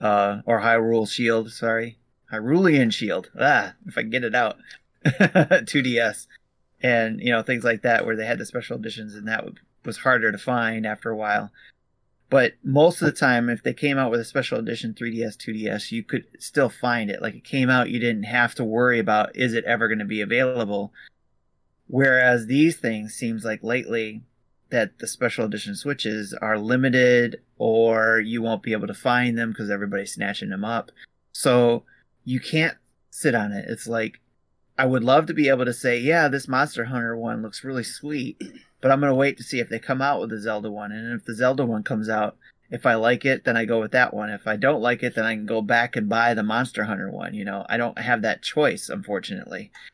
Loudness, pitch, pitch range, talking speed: -22 LUFS, 115 Hz, 110-125 Hz, 215 wpm